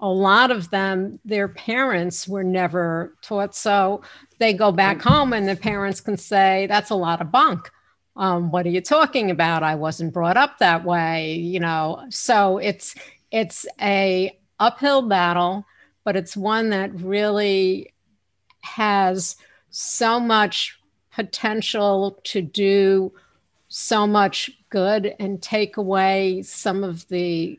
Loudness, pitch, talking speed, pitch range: -20 LUFS, 195 Hz, 140 wpm, 180-210 Hz